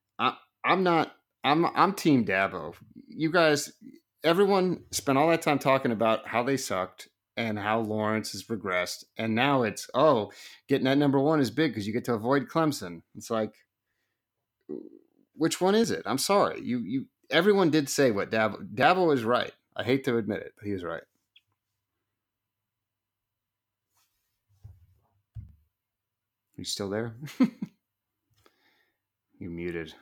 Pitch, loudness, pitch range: 115 Hz, -27 LUFS, 105-155 Hz